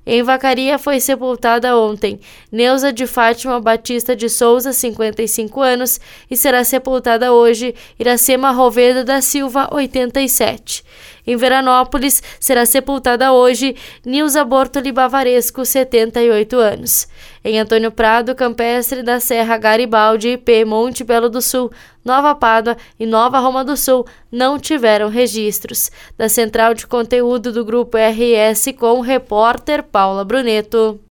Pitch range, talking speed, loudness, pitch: 230-260 Hz, 125 wpm, -14 LUFS, 245 Hz